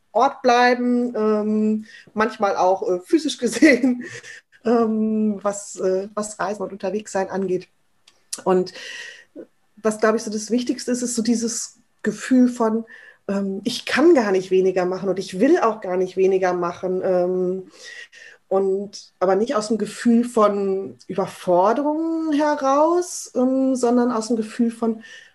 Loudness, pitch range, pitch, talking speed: -21 LUFS, 190-245 Hz, 220 Hz, 140 wpm